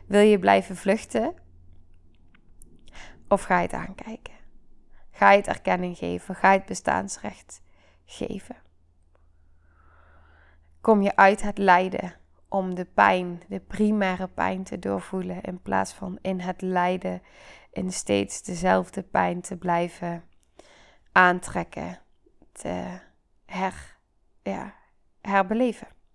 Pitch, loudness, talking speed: 175 Hz, -24 LUFS, 110 wpm